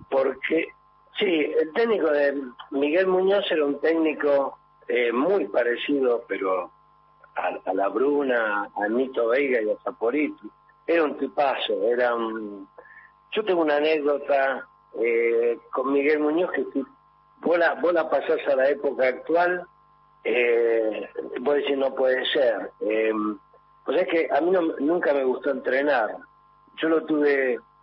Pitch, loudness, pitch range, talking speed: 140 Hz, -24 LUFS, 110-160 Hz, 150 wpm